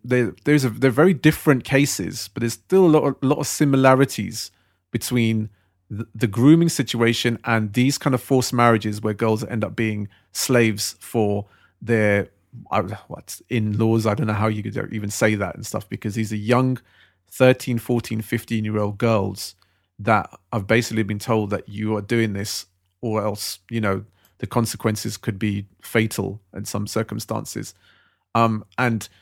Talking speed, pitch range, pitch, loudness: 170 wpm, 105-120 Hz, 110 Hz, -21 LUFS